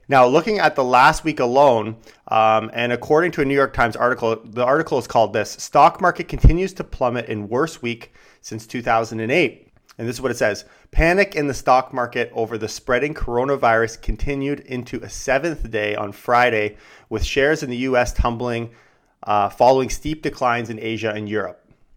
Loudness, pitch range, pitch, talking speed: -19 LUFS, 115-140 Hz, 120 Hz, 185 wpm